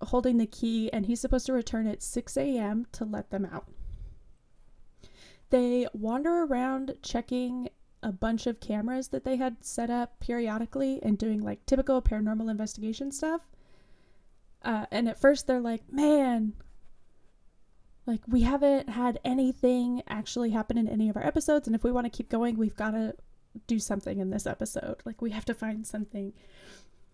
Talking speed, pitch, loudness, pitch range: 170 wpm, 235 Hz, -30 LUFS, 215-255 Hz